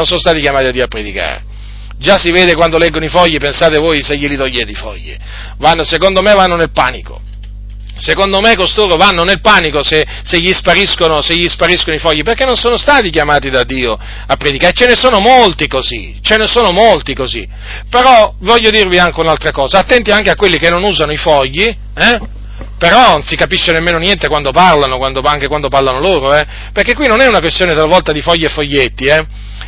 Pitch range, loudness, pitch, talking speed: 135-190 Hz, -9 LUFS, 160 Hz, 210 wpm